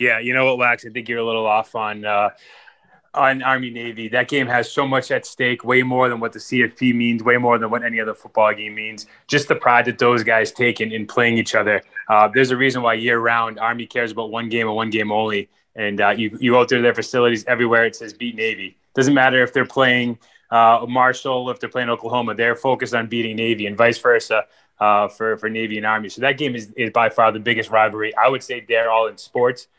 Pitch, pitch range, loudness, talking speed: 115 Hz, 110-125 Hz, -18 LUFS, 245 wpm